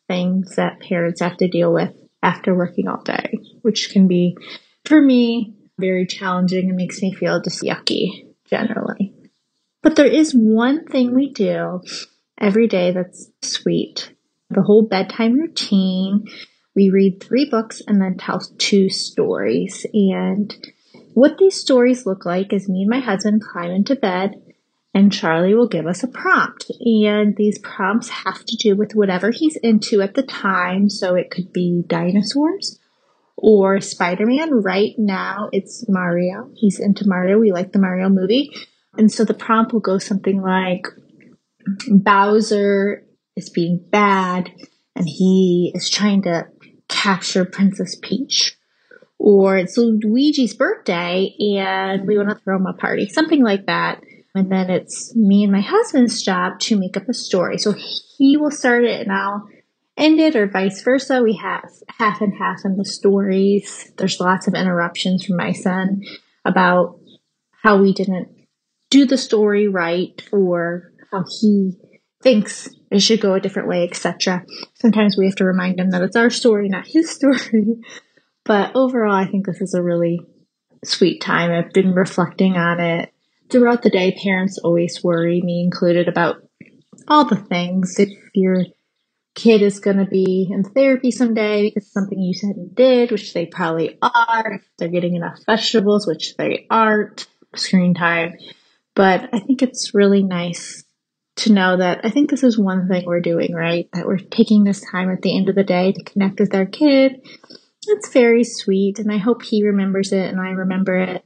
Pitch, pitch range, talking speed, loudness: 200 Hz, 185-230 Hz, 170 wpm, -17 LUFS